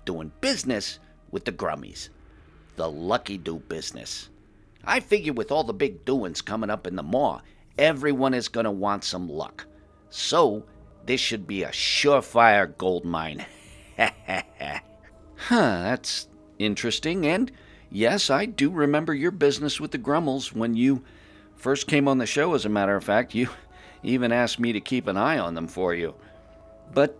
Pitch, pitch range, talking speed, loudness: 120 Hz, 105-145 Hz, 160 wpm, -25 LUFS